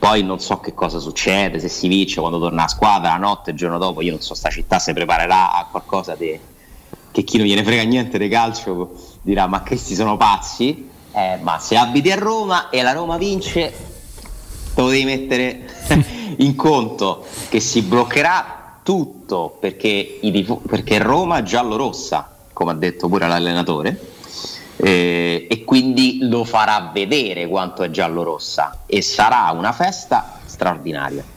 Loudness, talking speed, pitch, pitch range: -18 LUFS, 170 wpm, 100 Hz, 85-125 Hz